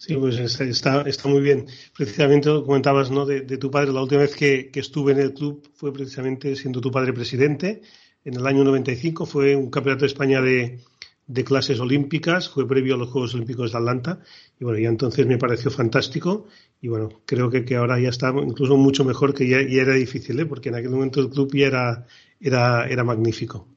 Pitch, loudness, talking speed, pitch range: 135 Hz, -21 LUFS, 215 wpm, 125-140 Hz